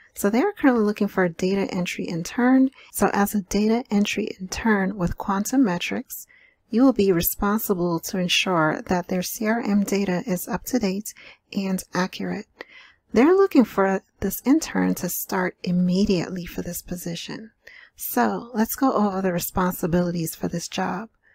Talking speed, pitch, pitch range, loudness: 155 wpm, 195 Hz, 180-225 Hz, -23 LUFS